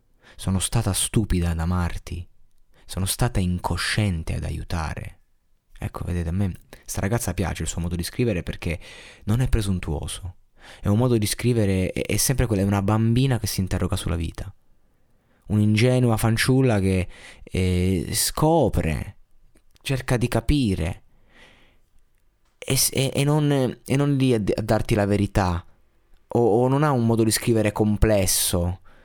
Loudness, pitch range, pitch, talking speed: -23 LUFS, 90-115 Hz, 100 Hz, 155 wpm